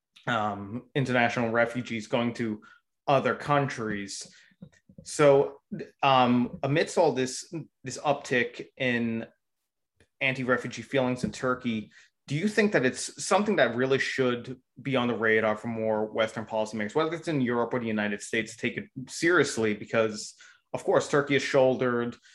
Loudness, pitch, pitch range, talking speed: -27 LUFS, 125 Hz, 115-135 Hz, 145 wpm